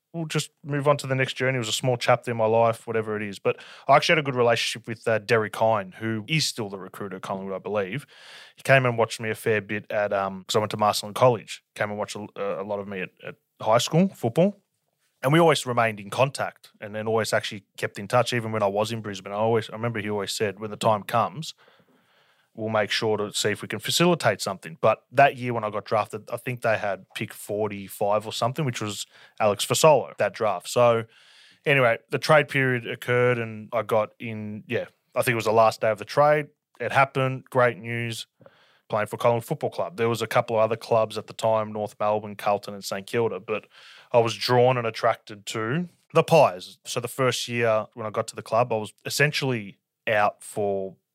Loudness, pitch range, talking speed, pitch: -24 LUFS, 105-125 Hz, 230 wpm, 115 Hz